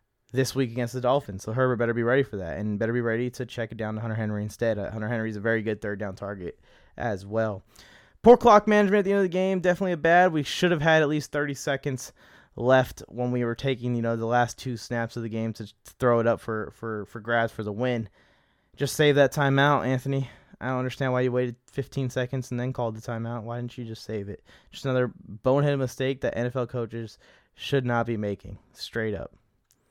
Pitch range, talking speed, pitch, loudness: 110-135 Hz, 235 wpm, 120 Hz, -26 LUFS